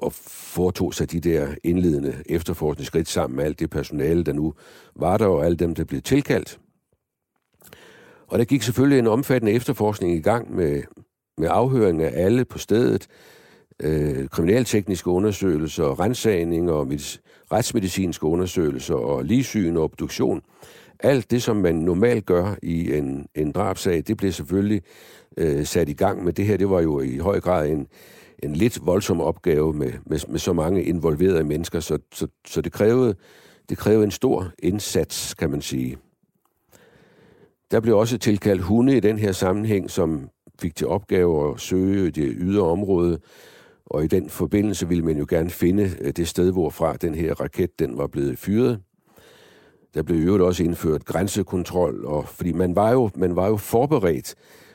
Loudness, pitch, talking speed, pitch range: -22 LUFS, 90 Hz, 170 wpm, 80-105 Hz